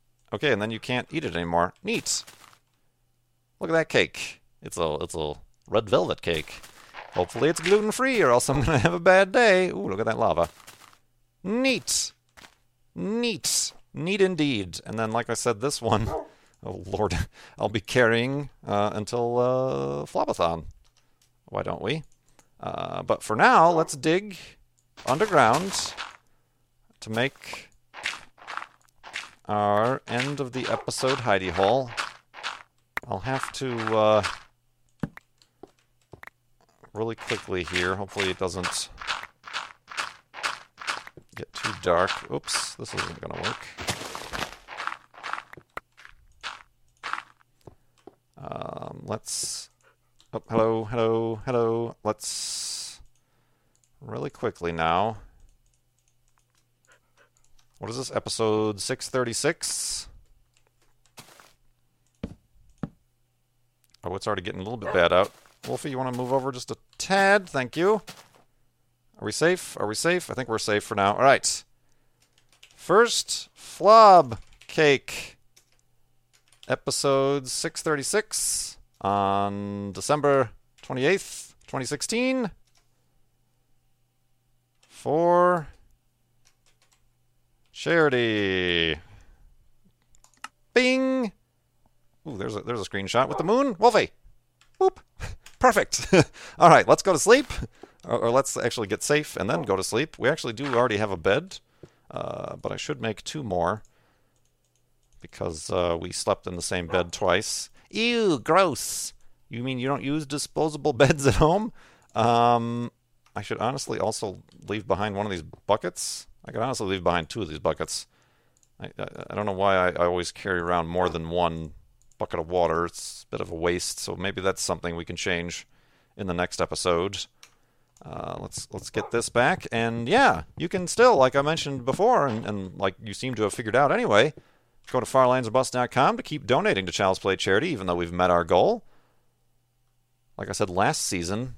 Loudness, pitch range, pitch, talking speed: -25 LUFS, 100-135 Hz, 120 Hz, 135 wpm